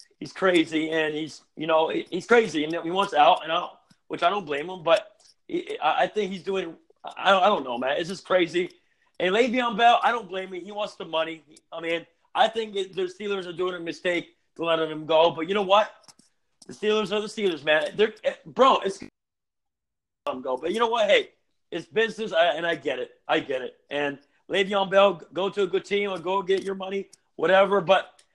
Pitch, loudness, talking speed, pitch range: 195 Hz, -25 LUFS, 220 wpm, 170-220 Hz